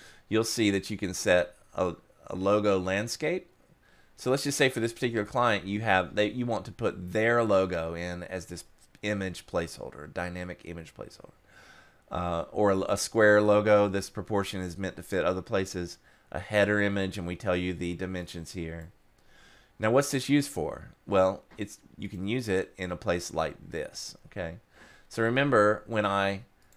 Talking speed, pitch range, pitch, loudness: 180 wpm, 90-110 Hz, 100 Hz, -28 LUFS